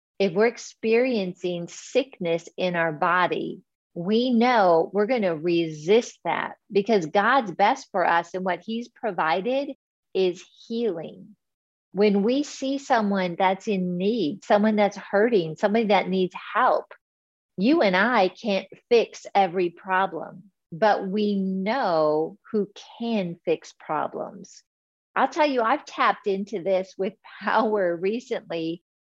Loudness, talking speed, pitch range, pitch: -24 LUFS, 130 wpm, 180-230 Hz, 200 Hz